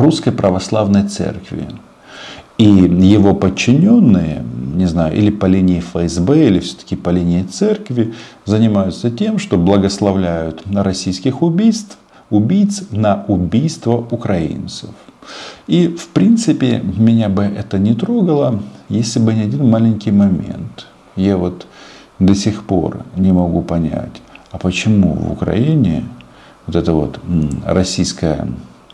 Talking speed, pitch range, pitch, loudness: 120 wpm, 90-115 Hz, 100 Hz, -14 LUFS